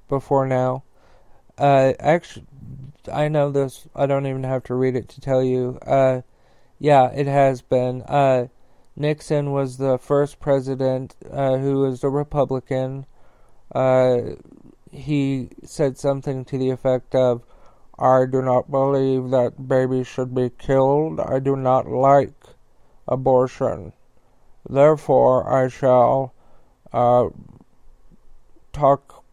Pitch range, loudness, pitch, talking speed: 130-140 Hz, -20 LUFS, 135 Hz, 125 wpm